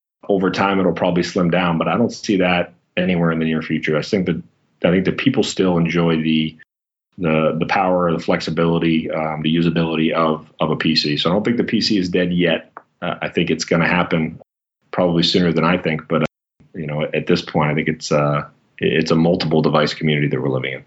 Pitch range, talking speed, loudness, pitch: 80-85 Hz, 225 wpm, -18 LUFS, 80 Hz